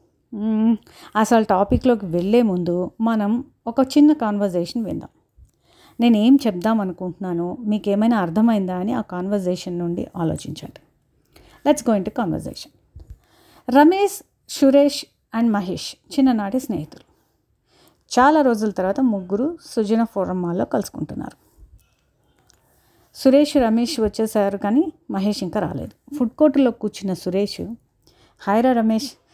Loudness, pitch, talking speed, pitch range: -20 LUFS, 220 Hz, 105 wpm, 200-255 Hz